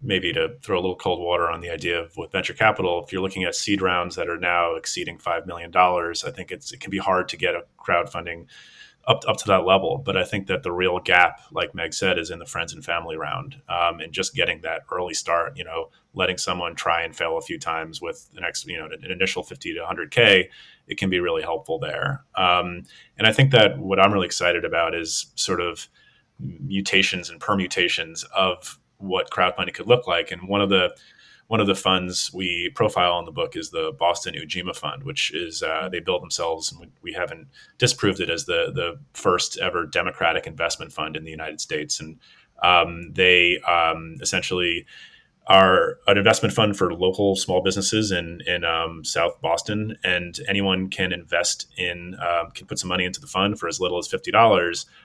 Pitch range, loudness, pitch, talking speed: 85-100 Hz, -22 LUFS, 90 Hz, 210 wpm